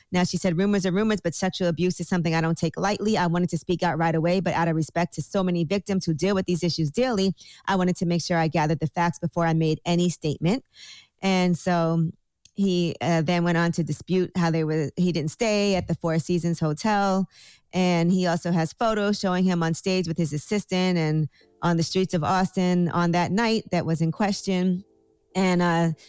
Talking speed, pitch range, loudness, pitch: 225 wpm, 165-190 Hz, -24 LUFS, 175 Hz